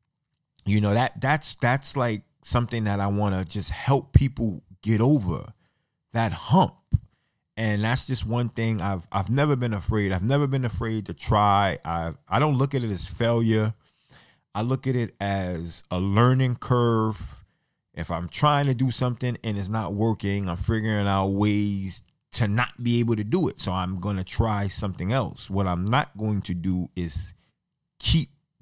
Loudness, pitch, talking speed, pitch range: -25 LUFS, 110 Hz, 180 wpm, 100-125 Hz